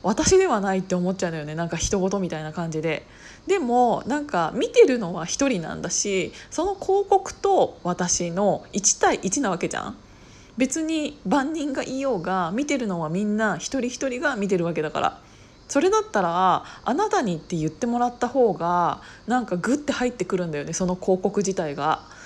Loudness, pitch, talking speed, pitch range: -23 LUFS, 205 Hz, 355 characters per minute, 180-275 Hz